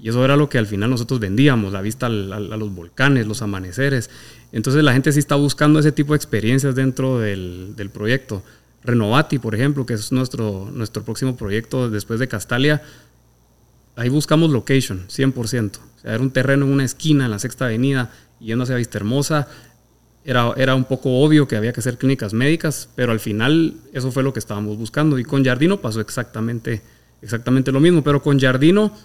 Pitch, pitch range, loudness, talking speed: 125 Hz, 110-140 Hz, -19 LUFS, 195 wpm